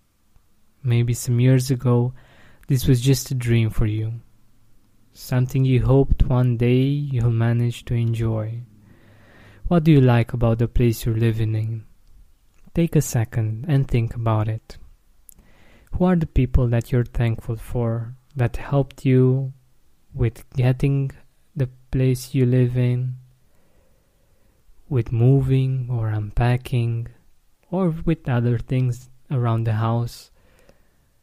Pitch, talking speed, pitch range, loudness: 120 Hz, 125 wpm, 115-130 Hz, -21 LUFS